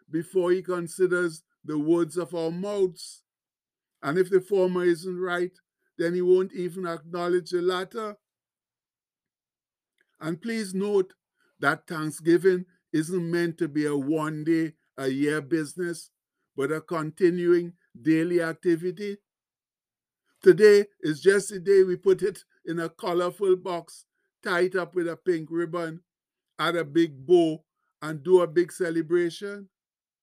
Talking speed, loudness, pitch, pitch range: 130 wpm, -26 LUFS, 175 Hz, 165-185 Hz